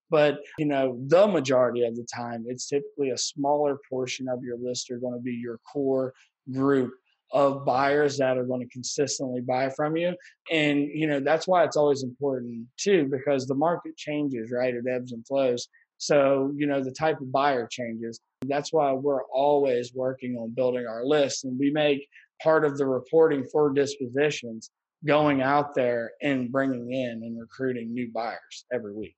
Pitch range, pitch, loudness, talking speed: 125-145 Hz, 135 Hz, -26 LUFS, 185 wpm